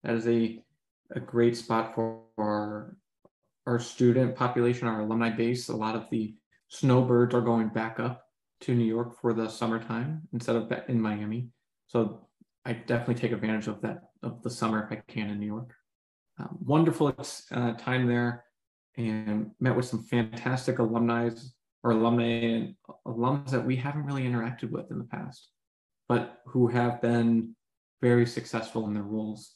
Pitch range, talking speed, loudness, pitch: 115-125 Hz, 165 wpm, -29 LUFS, 120 Hz